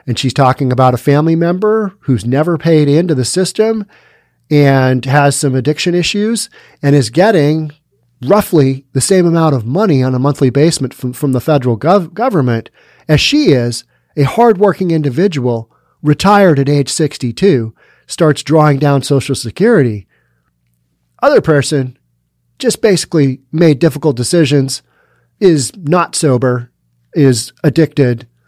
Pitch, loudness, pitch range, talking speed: 145 Hz, -12 LUFS, 125-165 Hz, 135 wpm